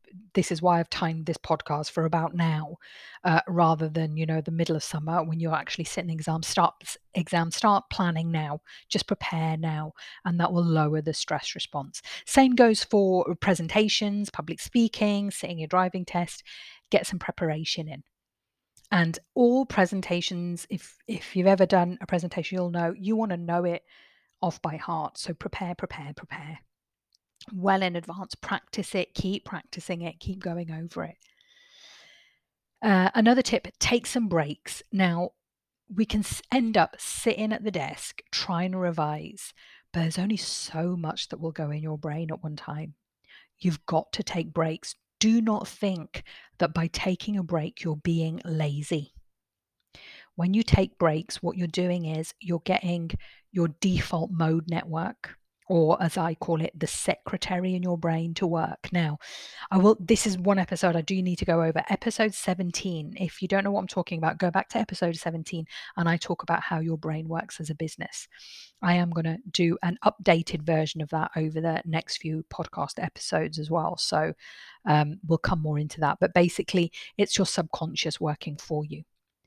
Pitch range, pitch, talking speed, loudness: 160-190 Hz, 170 Hz, 175 wpm, -27 LUFS